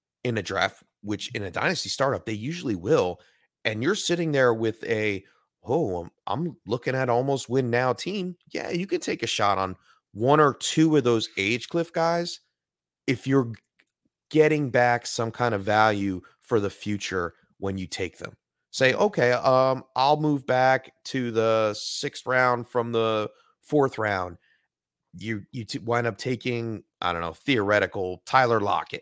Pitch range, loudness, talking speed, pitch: 110-140 Hz, -25 LUFS, 170 wpm, 120 Hz